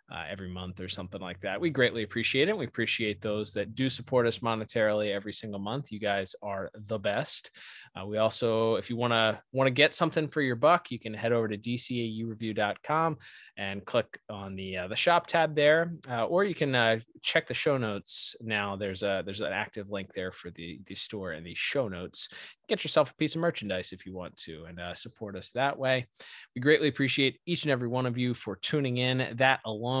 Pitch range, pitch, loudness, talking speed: 100-130 Hz, 115 Hz, -29 LUFS, 220 wpm